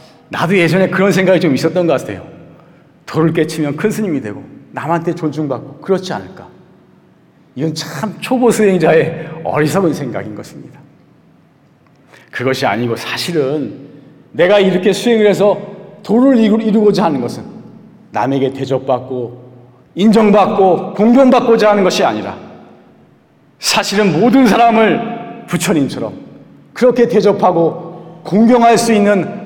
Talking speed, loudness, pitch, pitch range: 285 characters per minute, -13 LUFS, 190 Hz, 160-215 Hz